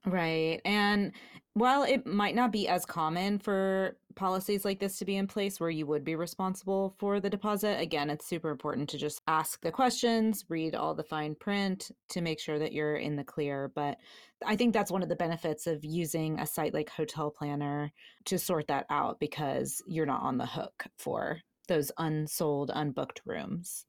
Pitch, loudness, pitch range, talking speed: 170 Hz, -32 LUFS, 150-200 Hz, 195 wpm